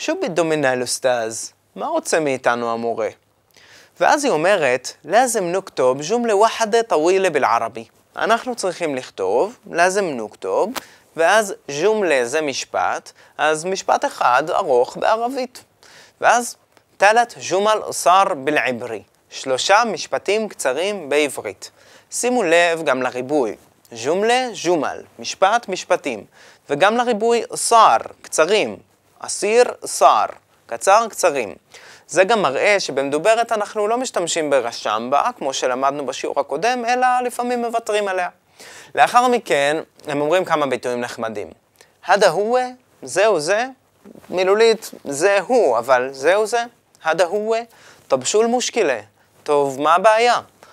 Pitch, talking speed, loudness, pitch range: 200 Hz, 115 wpm, -18 LUFS, 145-235 Hz